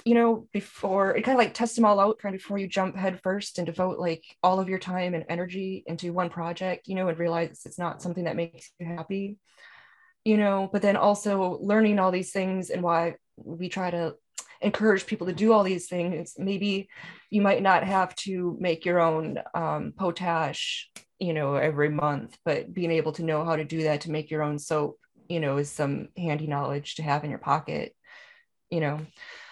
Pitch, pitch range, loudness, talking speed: 180 Hz, 165-200 Hz, -27 LUFS, 210 wpm